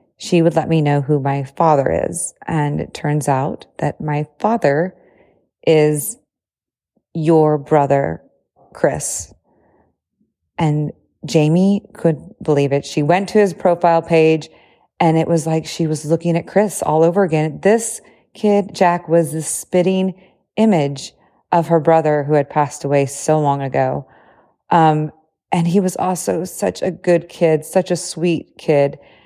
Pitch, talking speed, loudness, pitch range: 165 Hz, 150 wpm, -17 LUFS, 150-180 Hz